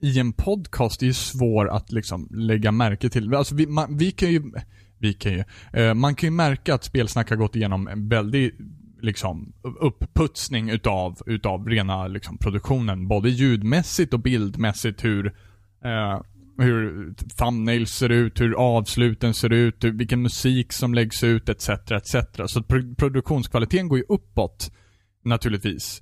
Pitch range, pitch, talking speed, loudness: 105-125 Hz, 115 Hz, 155 wpm, -23 LUFS